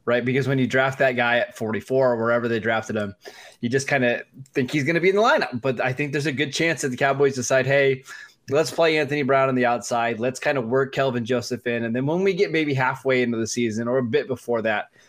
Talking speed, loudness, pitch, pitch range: 265 wpm, -22 LUFS, 130 Hz, 120-140 Hz